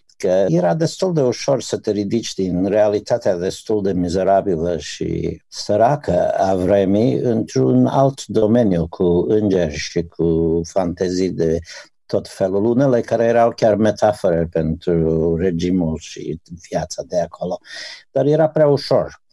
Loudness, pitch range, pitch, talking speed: -18 LUFS, 85-110 Hz, 95 Hz, 135 wpm